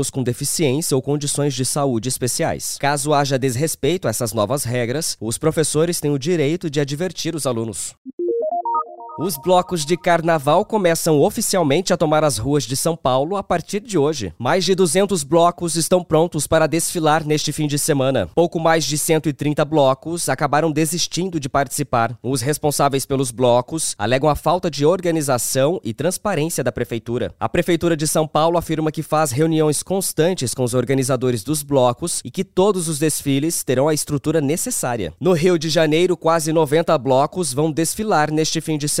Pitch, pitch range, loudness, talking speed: 155 Hz, 140-170 Hz, -19 LUFS, 170 wpm